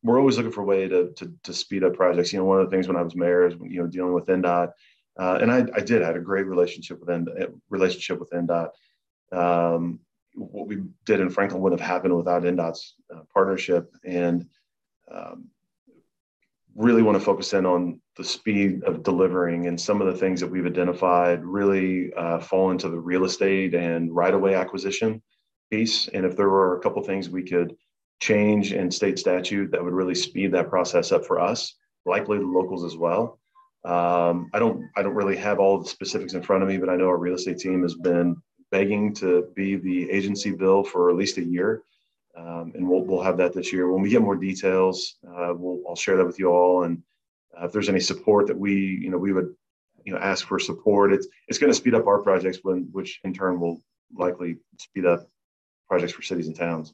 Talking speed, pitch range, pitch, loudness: 220 wpm, 85-95 Hz, 90 Hz, -23 LUFS